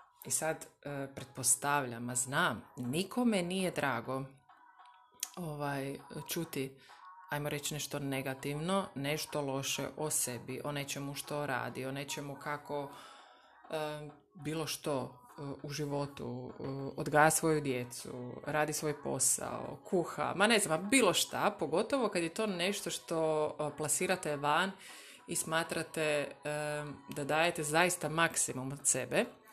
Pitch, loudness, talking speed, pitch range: 150 Hz, -34 LUFS, 130 wpm, 140-165 Hz